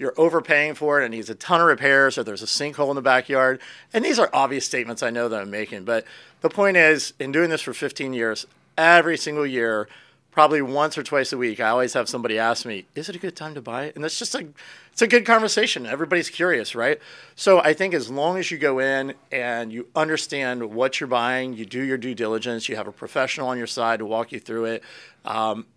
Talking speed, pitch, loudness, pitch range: 240 wpm, 135 Hz, -22 LUFS, 115-155 Hz